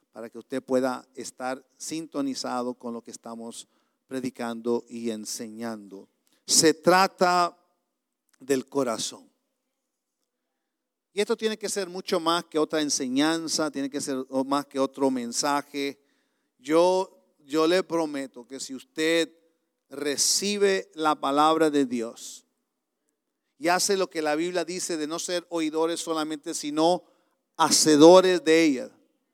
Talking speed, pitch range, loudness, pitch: 125 wpm, 130-175 Hz, -25 LUFS, 155 Hz